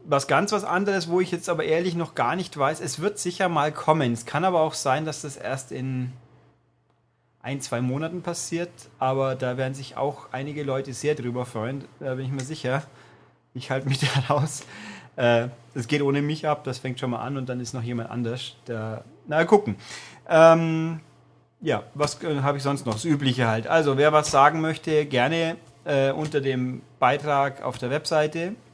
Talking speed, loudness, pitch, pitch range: 190 wpm, -25 LUFS, 140 Hz, 125-155 Hz